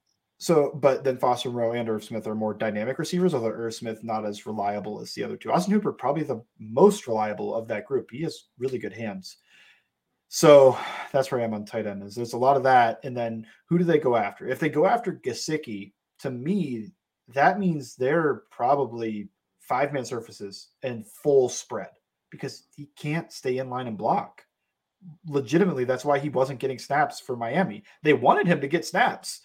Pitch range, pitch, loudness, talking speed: 110-150 Hz, 130 Hz, -25 LUFS, 200 wpm